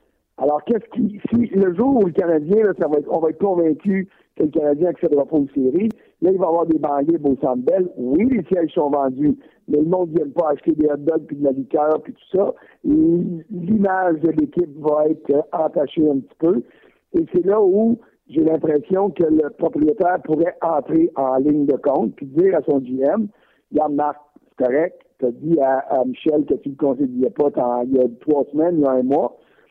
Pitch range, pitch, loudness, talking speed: 145-195 Hz, 160 Hz, -19 LUFS, 220 wpm